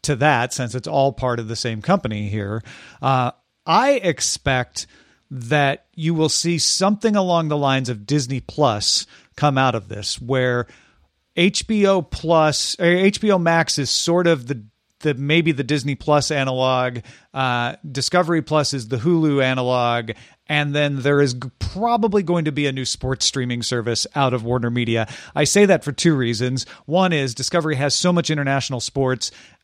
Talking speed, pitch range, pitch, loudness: 170 wpm, 125-160 Hz, 140 Hz, -19 LUFS